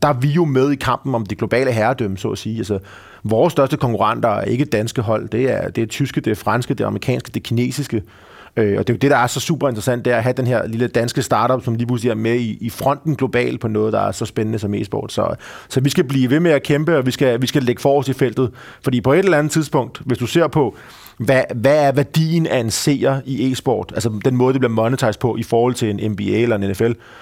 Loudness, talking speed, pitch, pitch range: -18 LUFS, 275 wpm, 125 Hz, 115-140 Hz